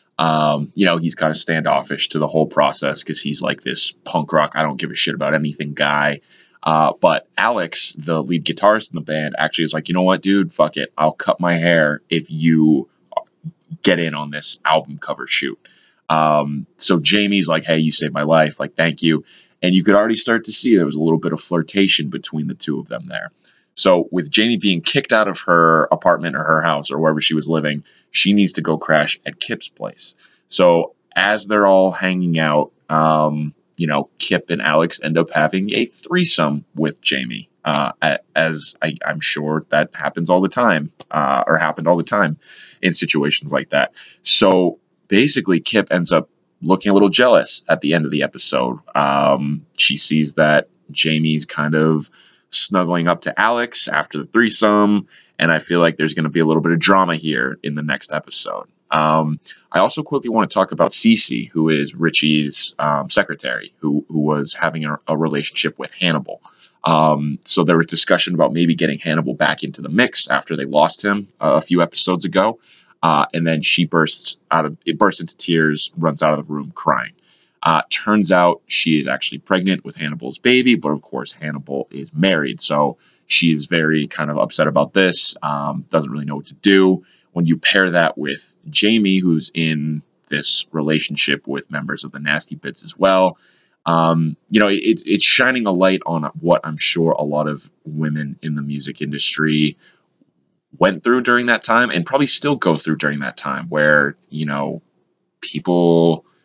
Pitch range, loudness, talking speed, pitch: 75-95 Hz, -17 LUFS, 195 wpm, 80 Hz